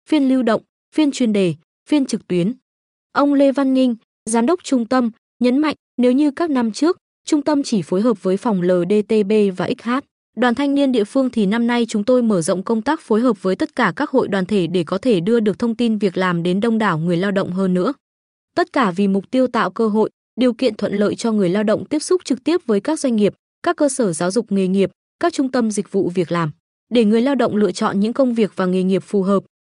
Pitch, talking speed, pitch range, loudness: 230 Hz, 255 wpm, 195-260 Hz, -18 LUFS